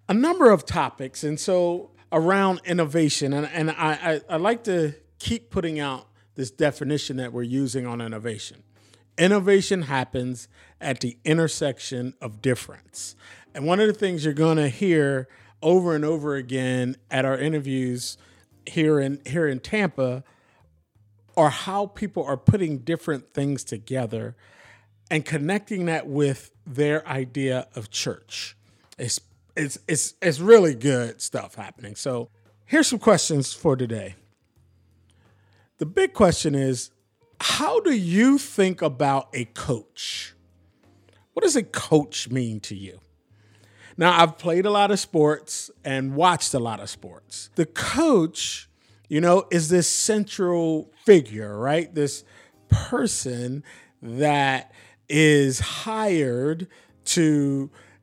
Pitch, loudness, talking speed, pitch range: 140 Hz, -23 LUFS, 130 wpm, 115-165 Hz